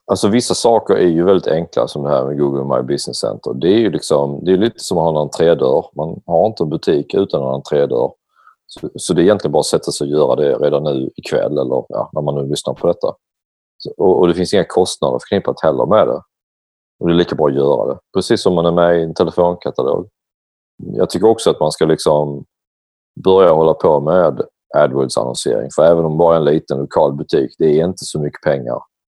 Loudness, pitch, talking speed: -15 LUFS, 85 Hz, 230 wpm